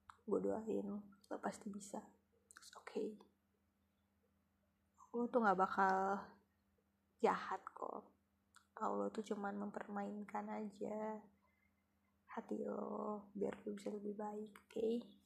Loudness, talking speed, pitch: -44 LUFS, 105 wpm, 200 Hz